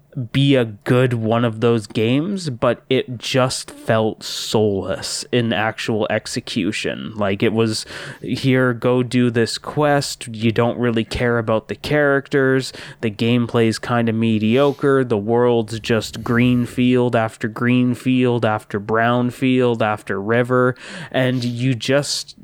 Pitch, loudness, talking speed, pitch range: 120 Hz, -19 LUFS, 140 wpm, 115-130 Hz